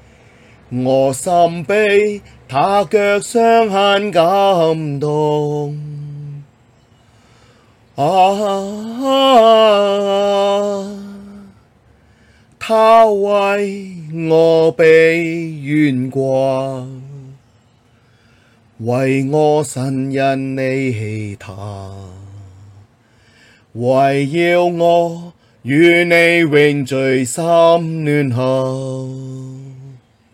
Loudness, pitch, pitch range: -14 LUFS, 145 Hz, 120-175 Hz